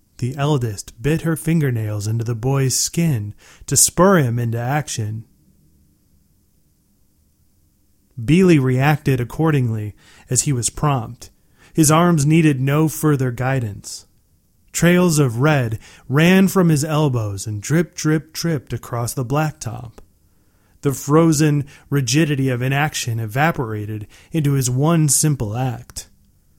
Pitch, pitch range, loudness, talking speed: 130 Hz, 105-155 Hz, -18 LUFS, 115 wpm